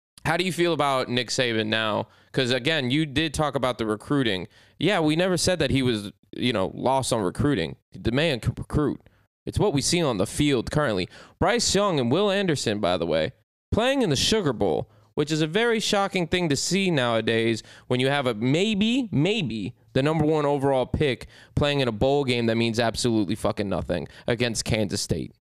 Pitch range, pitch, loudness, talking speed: 115-155 Hz, 130 Hz, -24 LUFS, 205 wpm